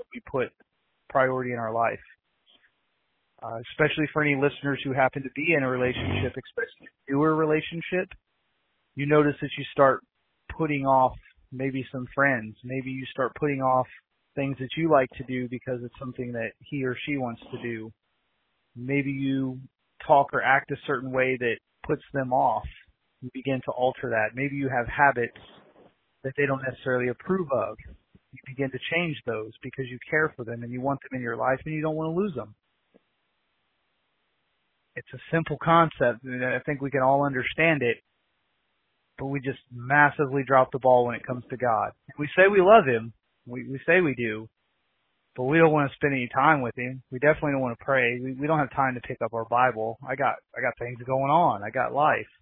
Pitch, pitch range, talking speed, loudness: 130 Hz, 125-145 Hz, 200 wpm, -26 LUFS